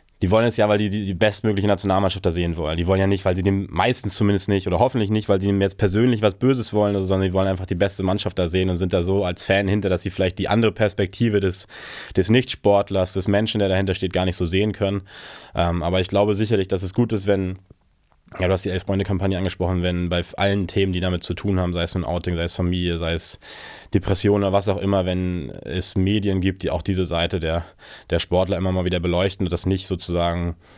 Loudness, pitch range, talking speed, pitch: -21 LUFS, 90-100 Hz, 245 wpm, 95 Hz